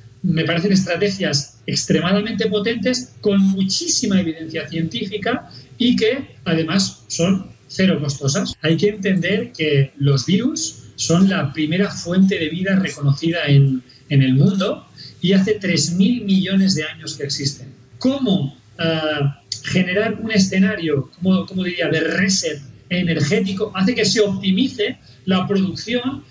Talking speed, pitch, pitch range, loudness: 130 wpm, 180 Hz, 150-200 Hz, -19 LUFS